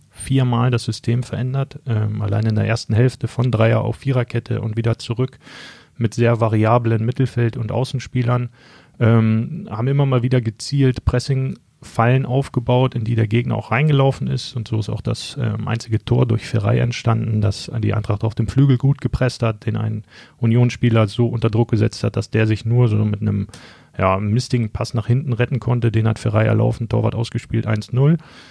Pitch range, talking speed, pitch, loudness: 110-125 Hz, 185 wpm, 120 Hz, -19 LUFS